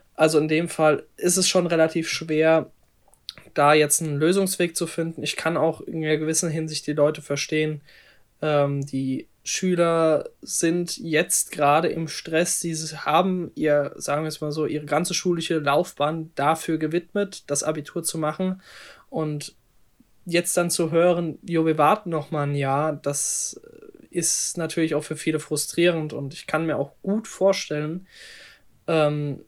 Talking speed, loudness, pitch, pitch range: 155 wpm, -23 LUFS, 160 Hz, 150-170 Hz